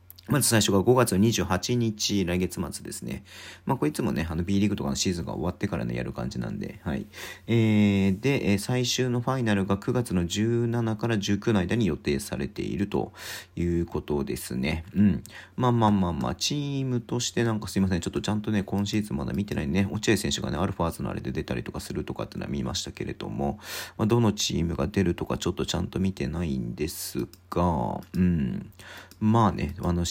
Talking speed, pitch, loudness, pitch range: 405 characters per minute, 100 Hz, -27 LUFS, 90-115 Hz